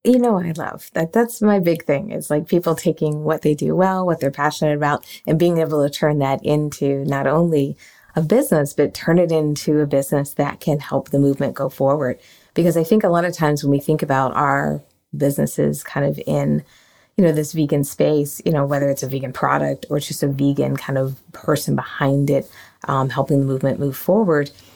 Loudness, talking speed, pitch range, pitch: -19 LUFS, 220 wpm, 140-160 Hz, 150 Hz